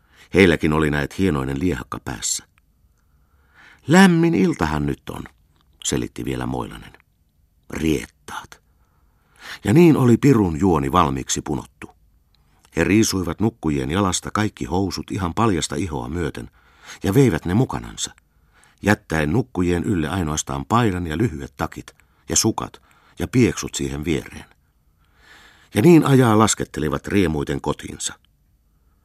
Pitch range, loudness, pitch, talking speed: 70-105 Hz, -20 LUFS, 80 Hz, 115 wpm